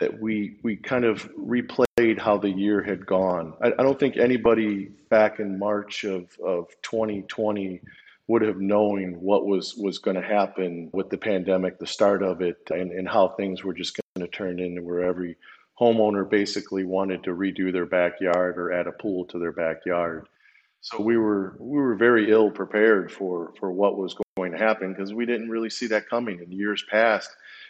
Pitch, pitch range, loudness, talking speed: 100 Hz, 90-110 Hz, -24 LUFS, 190 wpm